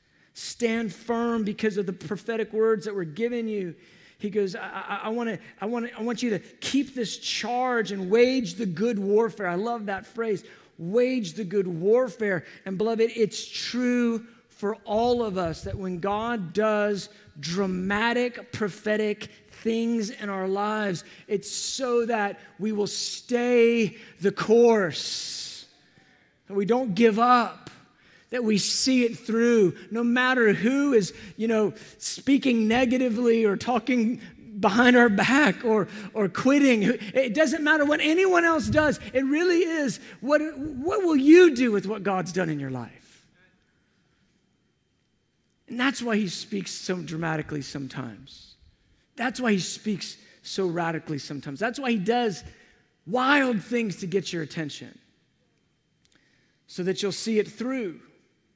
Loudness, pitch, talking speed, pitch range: -25 LUFS, 220 Hz, 150 wpm, 195-240 Hz